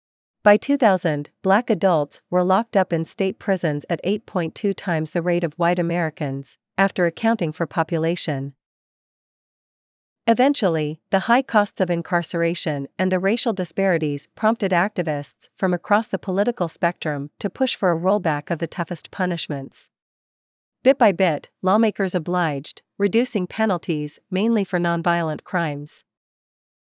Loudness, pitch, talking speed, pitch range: -22 LUFS, 180 Hz, 130 wpm, 160-200 Hz